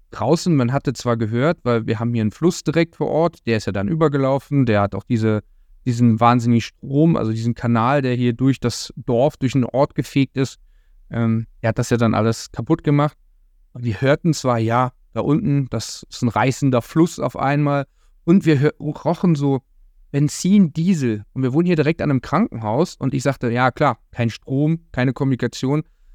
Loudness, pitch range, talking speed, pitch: -19 LUFS, 115-150 Hz, 195 wpm, 130 Hz